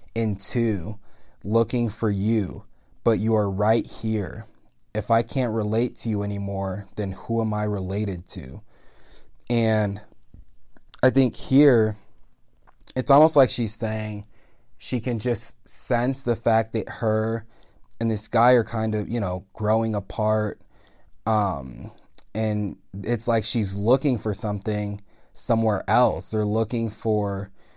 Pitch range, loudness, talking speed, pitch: 105-115 Hz, -24 LUFS, 135 wpm, 110 Hz